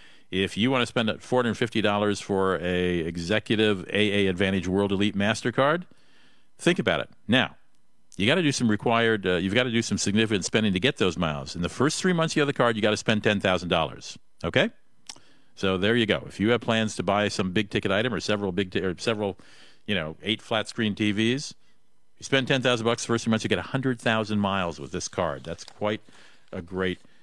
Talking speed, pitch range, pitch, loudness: 210 wpm, 95-115 Hz, 105 Hz, -25 LUFS